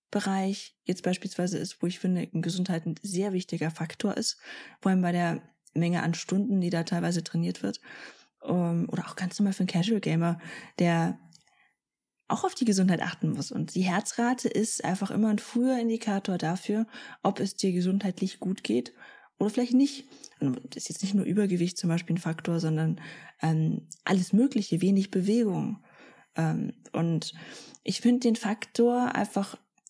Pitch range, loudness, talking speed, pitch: 170-210 Hz, -29 LUFS, 165 wpm, 185 Hz